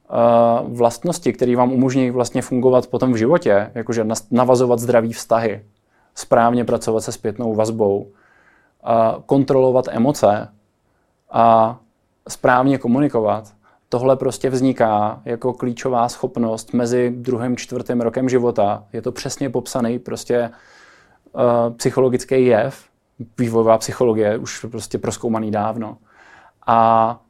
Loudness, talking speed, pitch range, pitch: -18 LUFS, 105 wpm, 110-125 Hz, 120 Hz